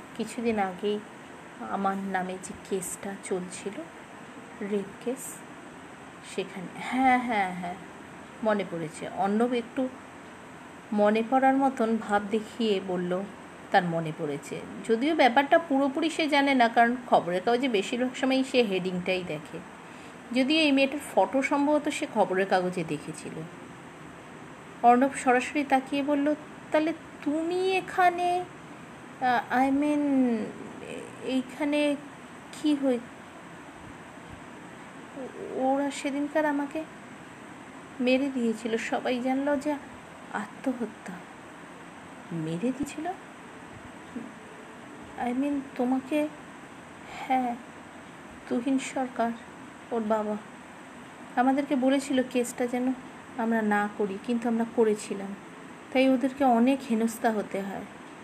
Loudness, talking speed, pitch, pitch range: -28 LUFS, 100 wpm, 245 Hz, 210-275 Hz